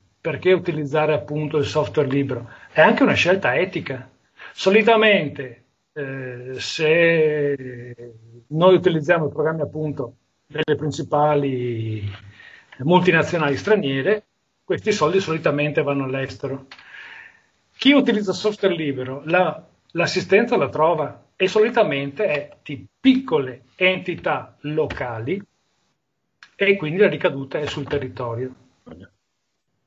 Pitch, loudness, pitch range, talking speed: 150 Hz, -20 LUFS, 135-185 Hz, 100 wpm